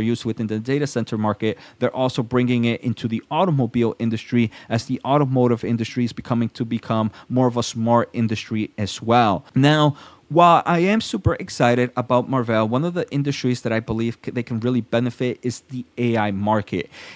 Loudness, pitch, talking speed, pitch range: -21 LUFS, 120 Hz, 180 wpm, 115-130 Hz